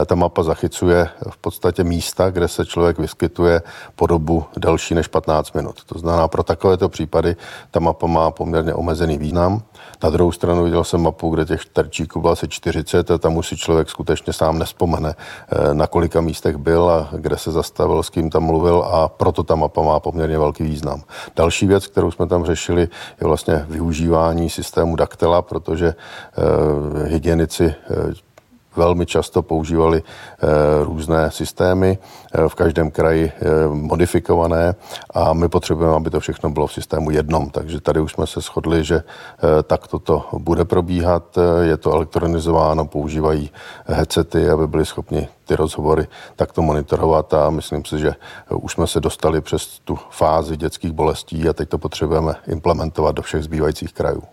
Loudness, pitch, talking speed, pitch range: -18 LUFS, 80 Hz, 165 wpm, 80-85 Hz